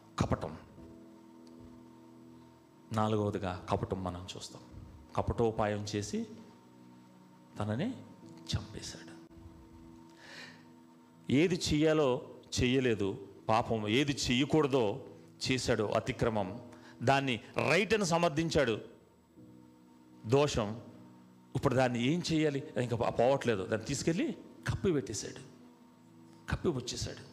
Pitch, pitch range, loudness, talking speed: 105 Hz, 80-125 Hz, -33 LUFS, 70 wpm